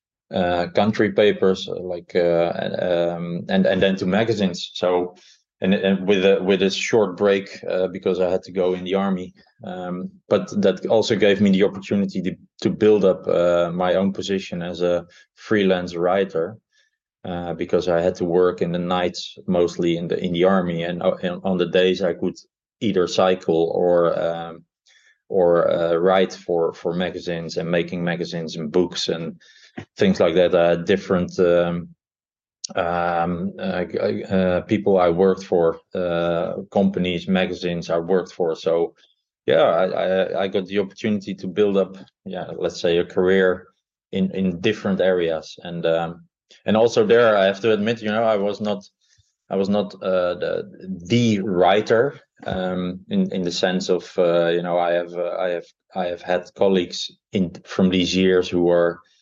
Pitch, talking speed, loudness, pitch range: 90 Hz, 170 wpm, -21 LUFS, 85-95 Hz